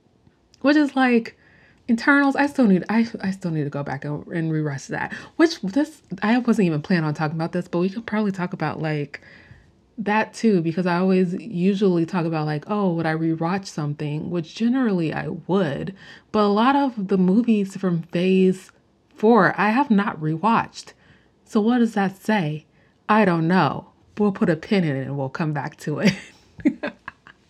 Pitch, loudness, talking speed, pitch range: 190 Hz, -22 LUFS, 190 wpm, 165-220 Hz